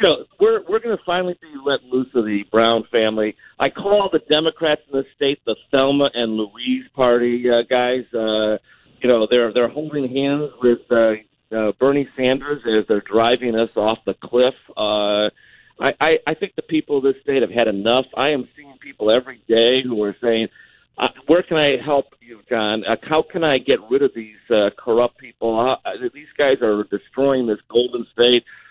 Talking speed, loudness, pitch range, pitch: 200 wpm, -19 LUFS, 115-145 Hz, 125 Hz